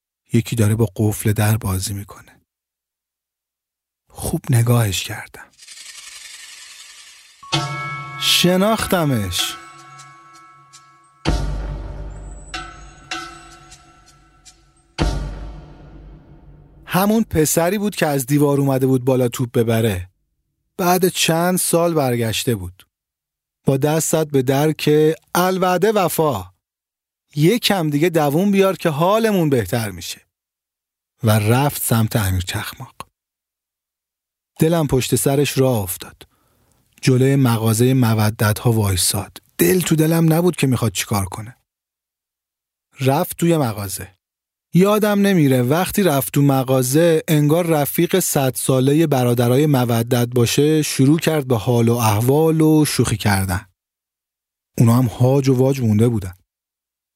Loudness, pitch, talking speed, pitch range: -17 LUFS, 130 Hz, 105 wpm, 105-160 Hz